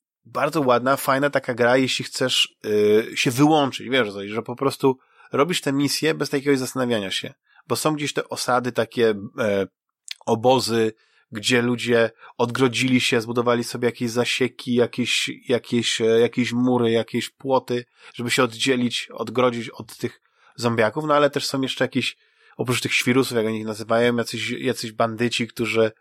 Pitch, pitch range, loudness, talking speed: 120 Hz, 115-130 Hz, -22 LUFS, 150 wpm